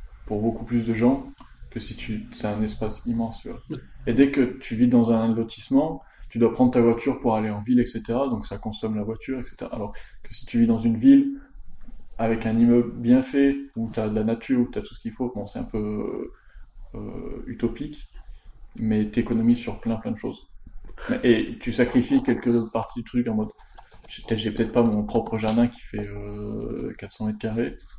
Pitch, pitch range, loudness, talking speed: 115 Hz, 110-120 Hz, -24 LUFS, 210 wpm